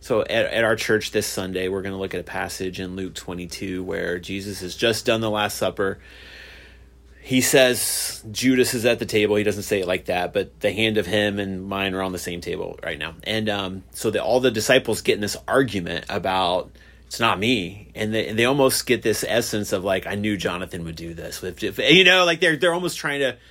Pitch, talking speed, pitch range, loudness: 105 Hz, 235 wpm, 95-120 Hz, -22 LUFS